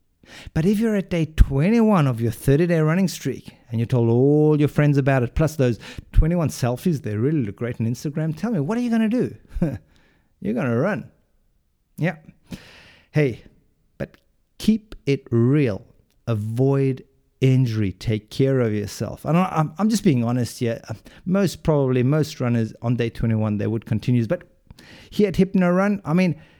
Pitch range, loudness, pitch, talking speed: 115-170 Hz, -21 LUFS, 135 Hz, 180 wpm